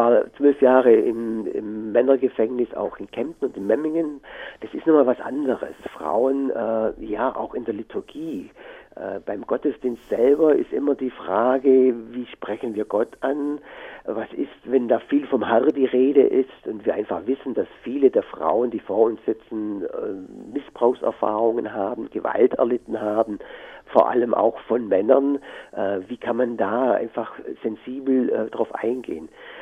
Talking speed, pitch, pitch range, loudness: 160 wpm, 130 Hz, 115-155 Hz, -22 LUFS